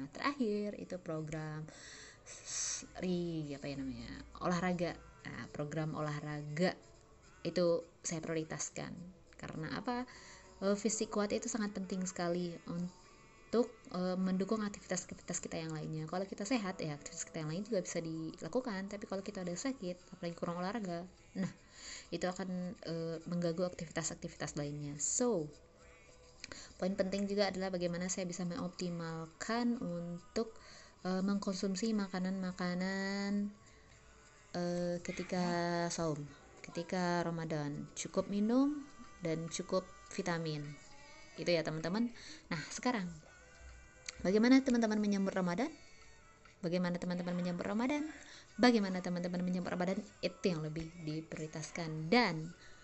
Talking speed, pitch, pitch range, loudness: 110 wpm, 180 Hz, 165-200 Hz, -38 LUFS